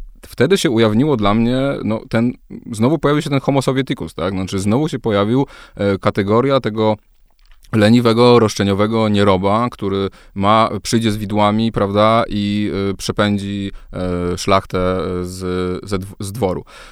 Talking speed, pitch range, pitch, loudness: 135 wpm, 100-115 Hz, 105 Hz, -16 LUFS